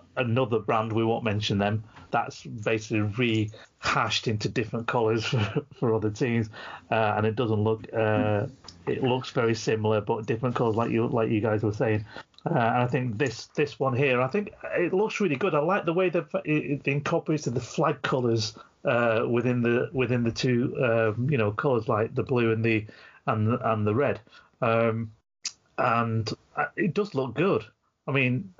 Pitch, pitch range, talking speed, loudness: 115 Hz, 110-135 Hz, 185 wpm, -27 LUFS